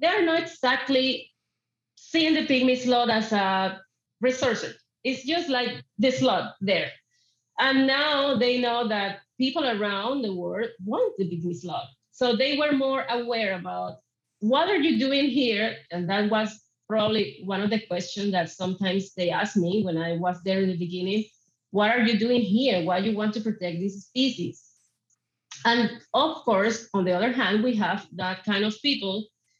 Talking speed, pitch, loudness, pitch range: 175 wpm, 220 Hz, -25 LUFS, 190-255 Hz